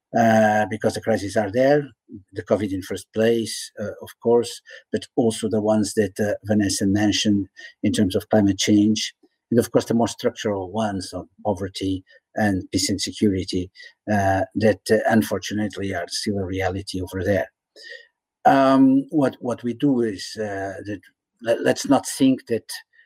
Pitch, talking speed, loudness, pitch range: 105 Hz, 160 wpm, -22 LUFS, 100-115 Hz